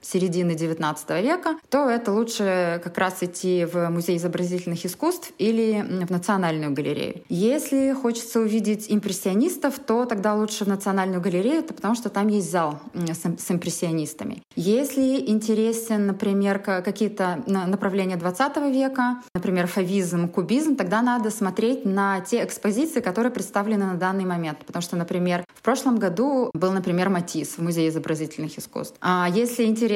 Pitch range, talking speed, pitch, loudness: 180-230 Hz, 140 wpm, 195 Hz, -24 LUFS